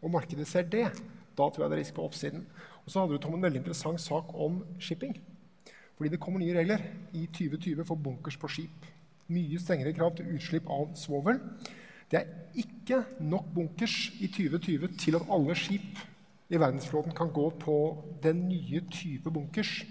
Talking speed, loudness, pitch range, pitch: 185 wpm, -33 LUFS, 160-190 Hz, 170 Hz